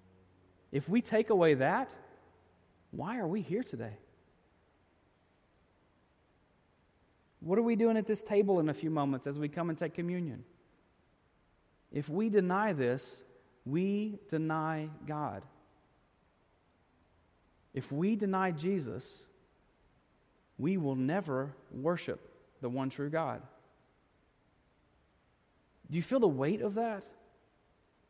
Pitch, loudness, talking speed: 150 Hz, -34 LUFS, 115 wpm